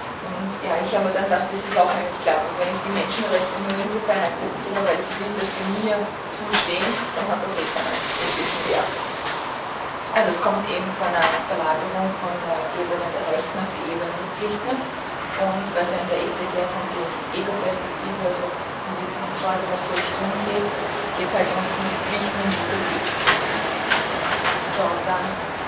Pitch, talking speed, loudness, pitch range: 185 Hz, 175 wpm, -23 LUFS, 175-195 Hz